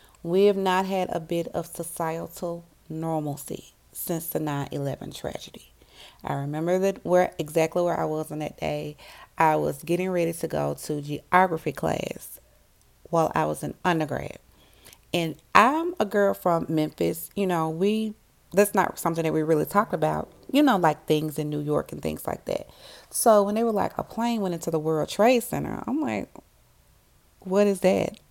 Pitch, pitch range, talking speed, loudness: 170 Hz, 155-195 Hz, 180 wpm, -25 LUFS